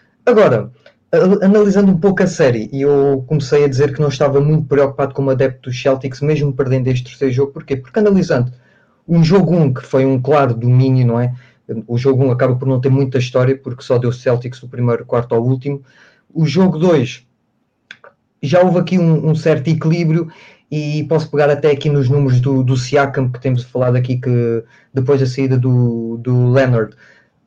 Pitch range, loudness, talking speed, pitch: 125-150 Hz, -15 LUFS, 190 wpm, 135 Hz